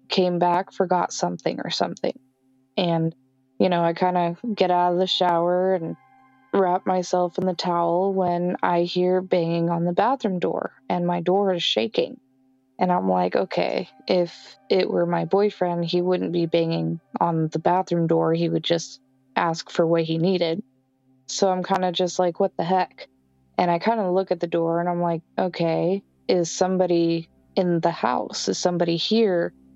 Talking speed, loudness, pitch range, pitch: 180 wpm, -23 LUFS, 165-185 Hz, 175 Hz